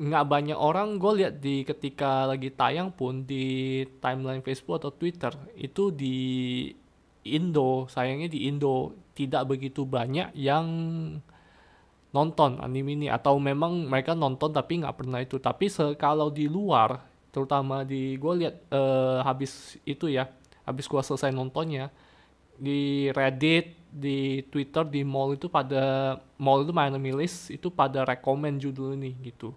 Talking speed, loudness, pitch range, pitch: 140 wpm, -28 LUFS, 130-150 Hz, 140 Hz